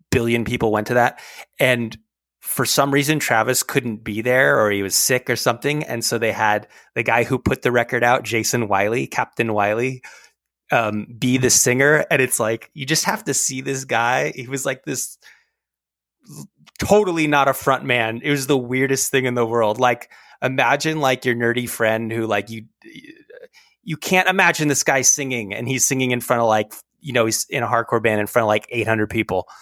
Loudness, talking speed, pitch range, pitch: -19 LUFS, 205 wpm, 115-140 Hz, 125 Hz